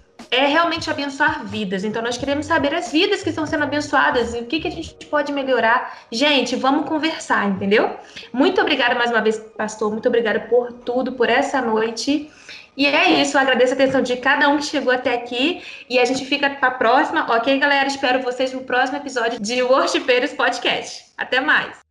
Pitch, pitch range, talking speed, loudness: 265 Hz, 240-295 Hz, 200 wpm, -19 LUFS